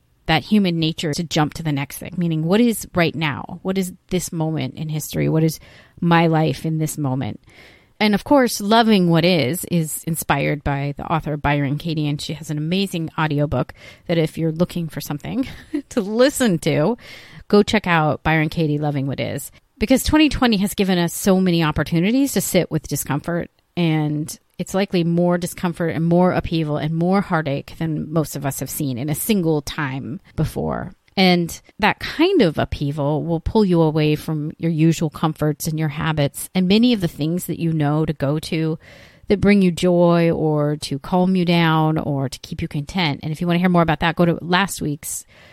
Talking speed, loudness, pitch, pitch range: 200 wpm, -20 LUFS, 165 Hz, 150-180 Hz